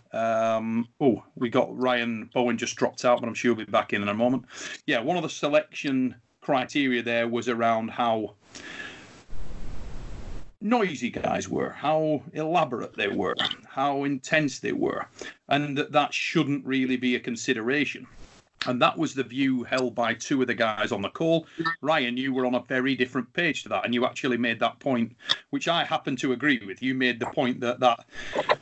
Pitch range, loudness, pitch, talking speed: 120-140 Hz, -26 LUFS, 125 Hz, 190 wpm